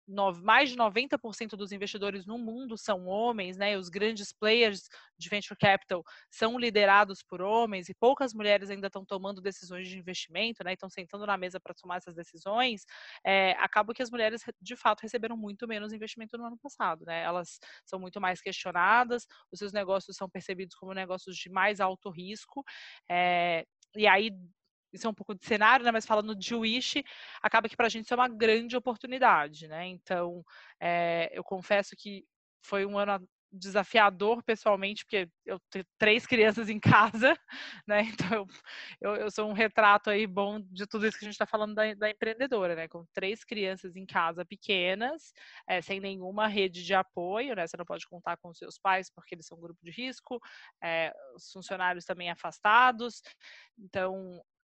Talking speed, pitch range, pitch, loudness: 185 wpm, 185-225 Hz, 200 Hz, -29 LUFS